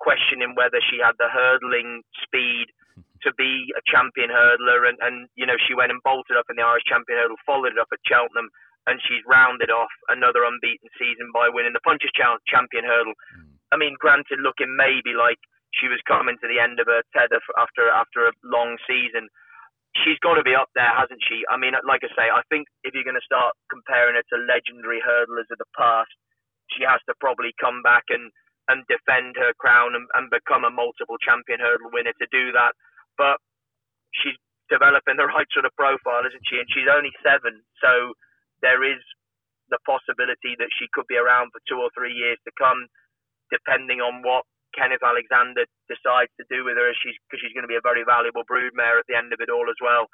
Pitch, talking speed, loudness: 125 Hz, 205 wpm, -20 LUFS